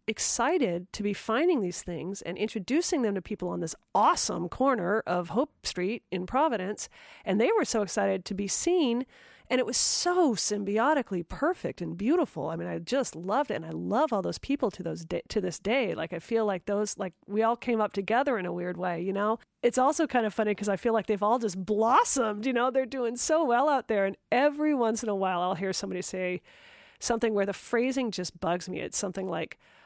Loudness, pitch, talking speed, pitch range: -28 LUFS, 215 Hz, 225 wpm, 190-260 Hz